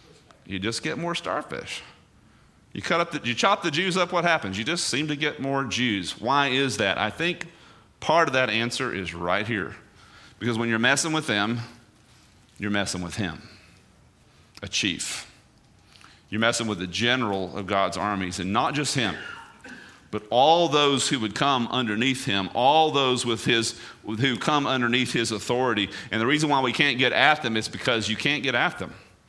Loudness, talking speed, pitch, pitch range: -24 LUFS, 190 wpm, 120 Hz, 105-145 Hz